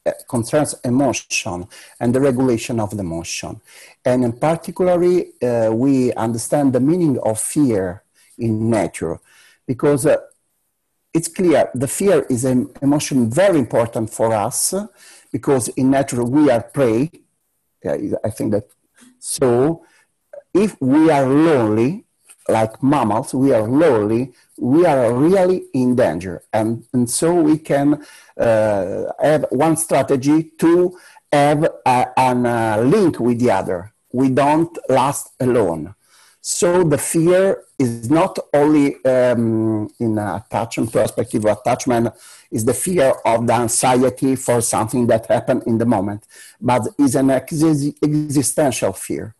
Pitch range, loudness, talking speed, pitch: 115-150 Hz, -17 LUFS, 130 wpm, 130 Hz